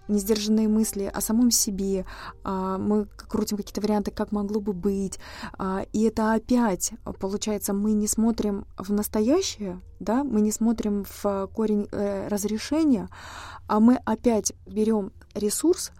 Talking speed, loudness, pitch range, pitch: 130 wpm, -25 LUFS, 205-220 Hz, 210 Hz